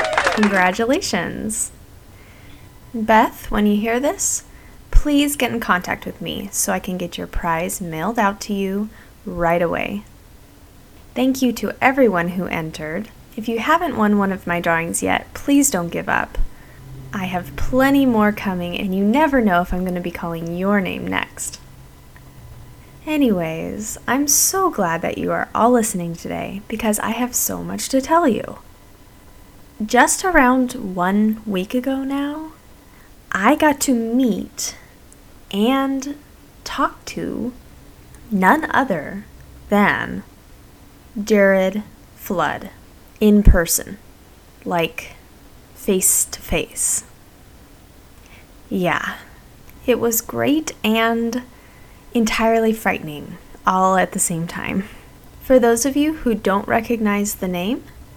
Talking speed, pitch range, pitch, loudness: 130 wpm, 175-245 Hz, 210 Hz, -19 LUFS